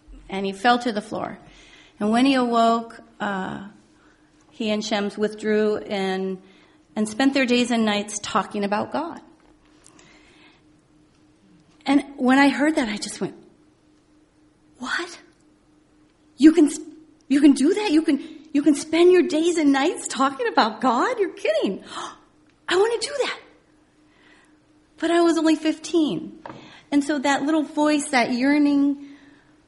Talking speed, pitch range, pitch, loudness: 145 wpm, 235-315 Hz, 285 Hz, -21 LUFS